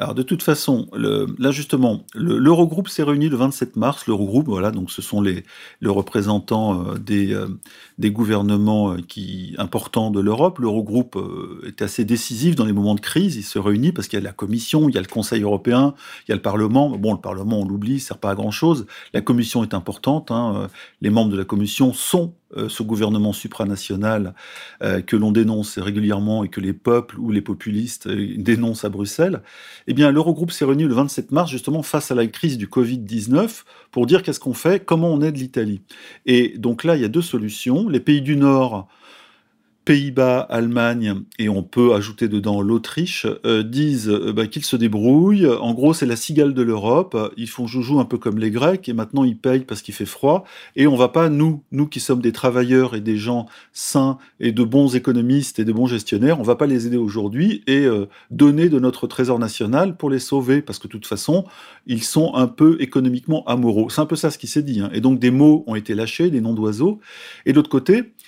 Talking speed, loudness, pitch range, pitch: 215 wpm, -19 LUFS, 105-140 Hz, 120 Hz